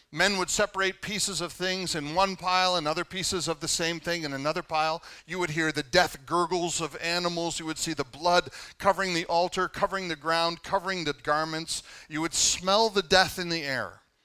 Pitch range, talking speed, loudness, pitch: 160-185 Hz, 205 wpm, -27 LUFS, 170 Hz